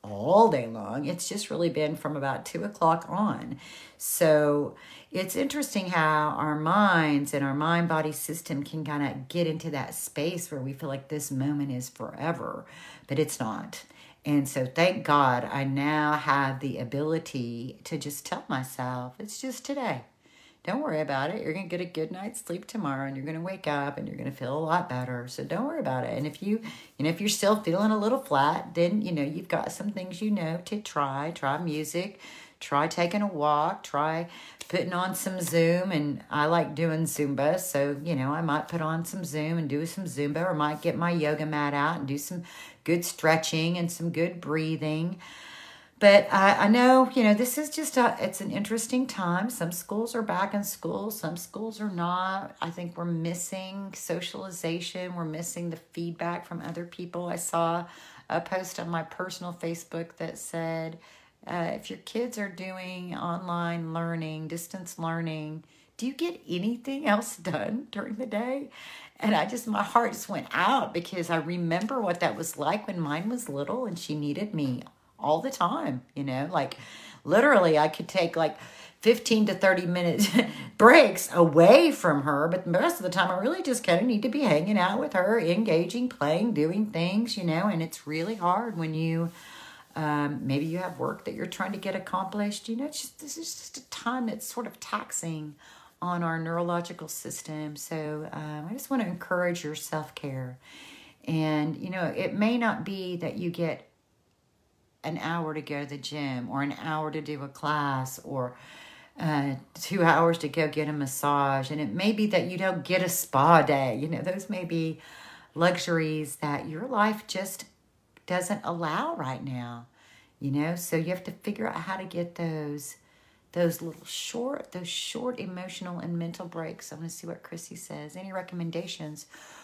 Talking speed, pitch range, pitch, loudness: 195 wpm, 150-190 Hz, 170 Hz, -28 LUFS